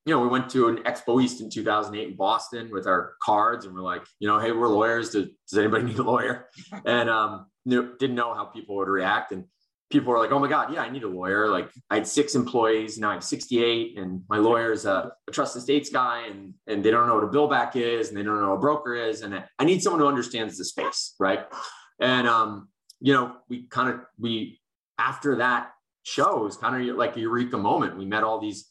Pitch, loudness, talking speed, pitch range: 115 Hz, -25 LUFS, 240 wpm, 105-125 Hz